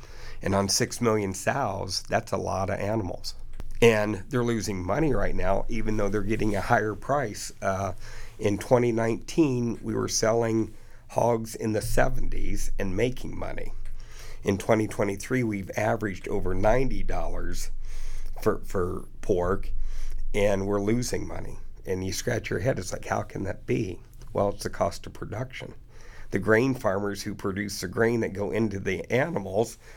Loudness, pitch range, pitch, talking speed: -28 LUFS, 100-115 Hz, 105 Hz, 155 wpm